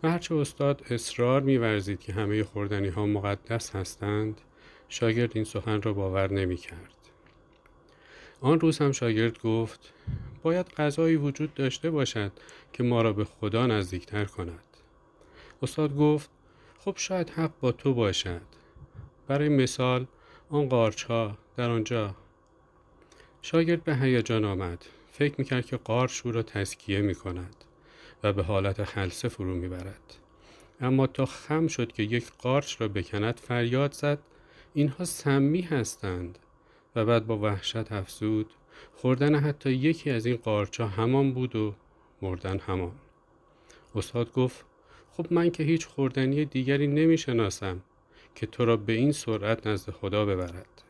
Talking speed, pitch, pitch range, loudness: 135 wpm, 115 Hz, 100-140 Hz, -28 LUFS